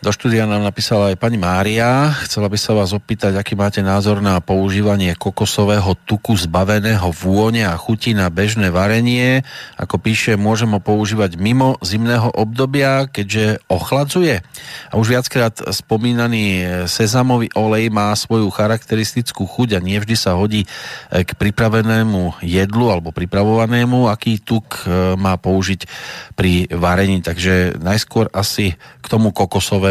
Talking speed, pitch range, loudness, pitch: 130 wpm, 95-115 Hz, -16 LUFS, 105 Hz